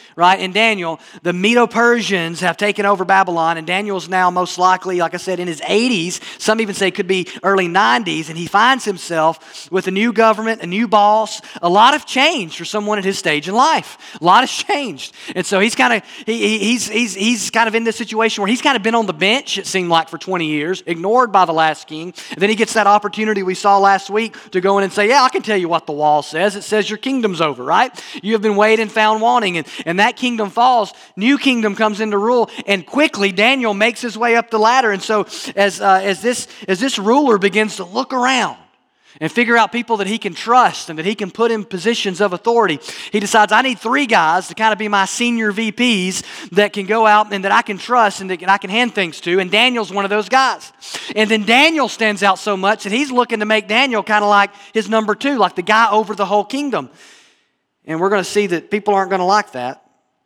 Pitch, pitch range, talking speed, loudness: 210 Hz, 190-225 Hz, 245 wpm, -15 LUFS